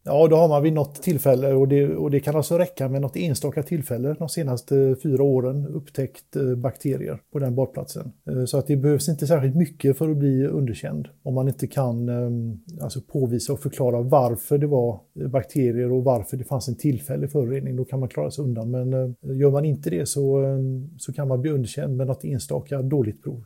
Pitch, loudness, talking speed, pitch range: 135 Hz, -23 LUFS, 200 wpm, 130-145 Hz